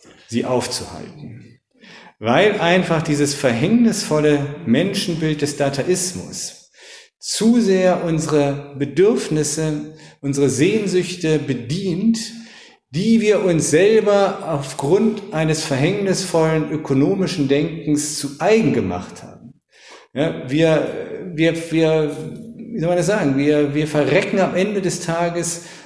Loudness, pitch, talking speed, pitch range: -18 LUFS, 165 Hz, 105 wpm, 150-195 Hz